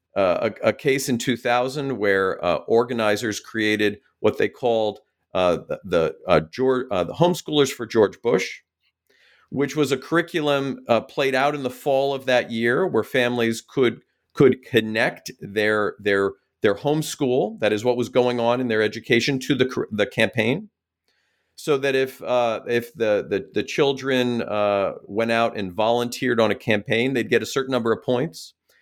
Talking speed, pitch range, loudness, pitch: 175 wpm, 110-135 Hz, -22 LUFS, 120 Hz